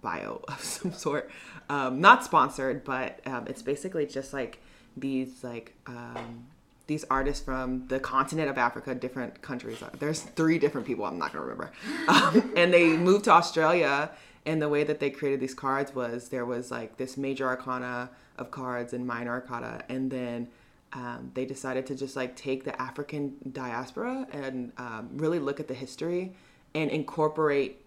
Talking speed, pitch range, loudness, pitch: 170 wpm, 125-150 Hz, -28 LUFS, 135 Hz